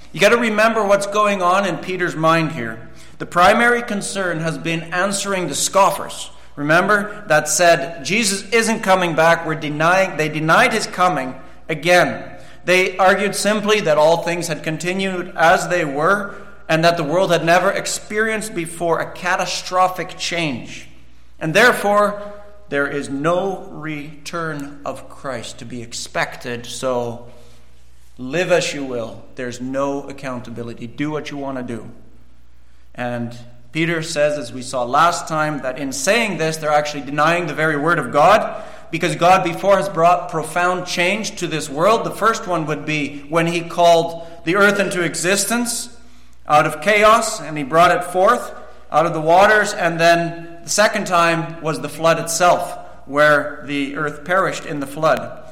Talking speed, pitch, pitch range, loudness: 160 wpm, 170 Hz, 150-190 Hz, -17 LUFS